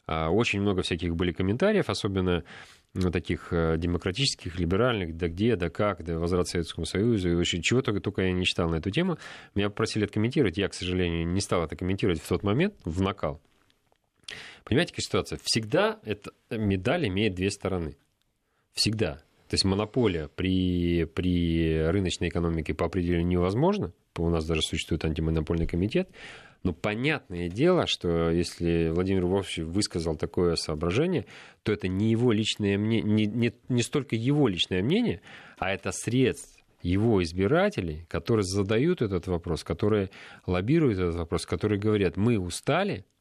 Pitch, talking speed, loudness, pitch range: 95 Hz, 150 wpm, -27 LUFS, 85-105 Hz